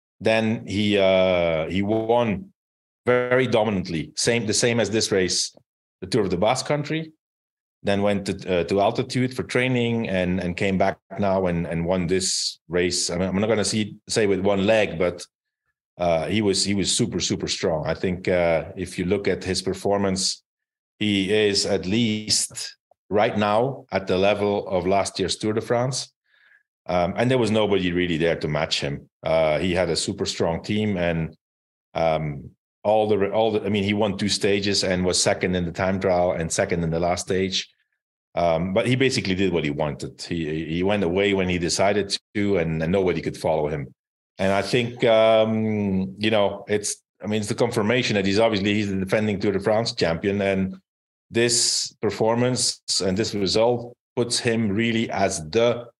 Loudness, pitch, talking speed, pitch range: -22 LUFS, 100 Hz, 190 wpm, 90-110 Hz